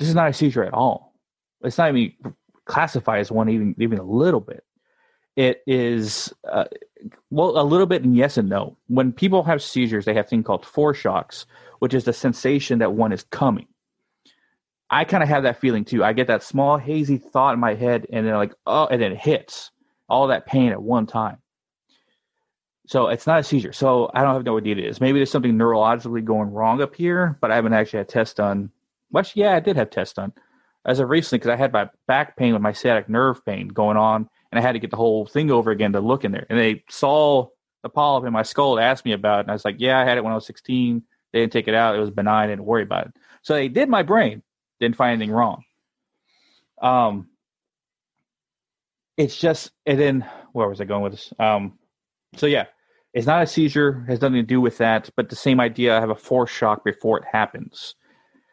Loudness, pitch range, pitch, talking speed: -20 LUFS, 110-135 Hz, 120 Hz, 230 wpm